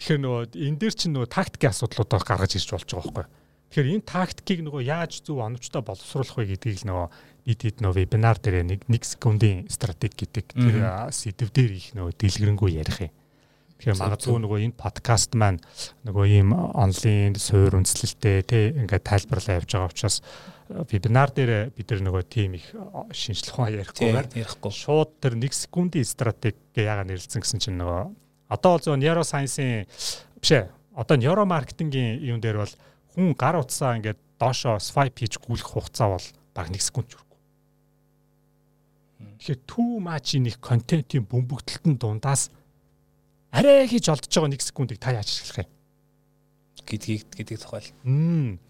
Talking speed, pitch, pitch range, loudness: 155 wpm, 120 Hz, 105-145 Hz, -24 LUFS